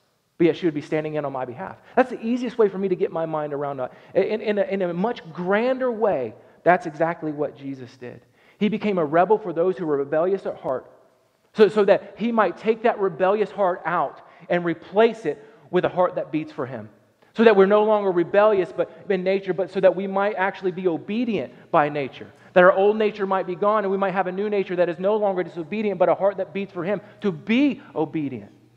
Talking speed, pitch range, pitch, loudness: 235 wpm, 160-205 Hz, 190 Hz, -22 LUFS